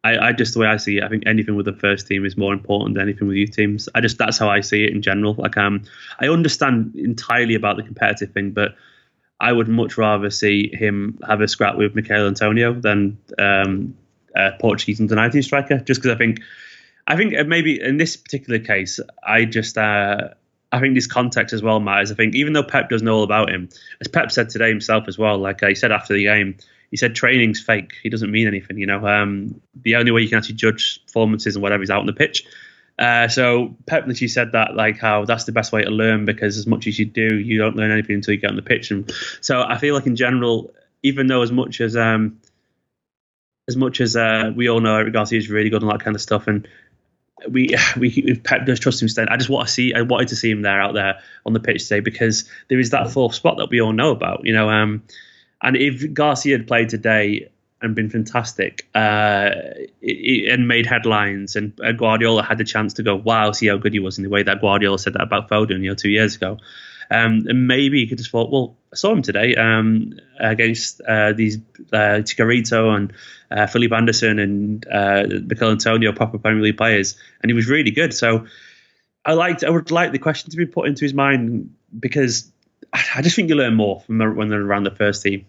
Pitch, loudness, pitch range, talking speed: 110 Hz, -18 LUFS, 105-120 Hz, 235 wpm